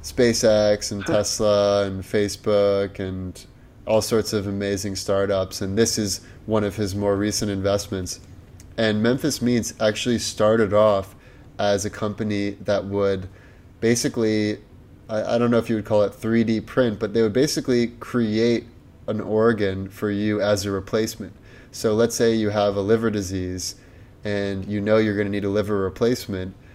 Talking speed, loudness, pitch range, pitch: 160 wpm, -22 LUFS, 100-115 Hz, 105 Hz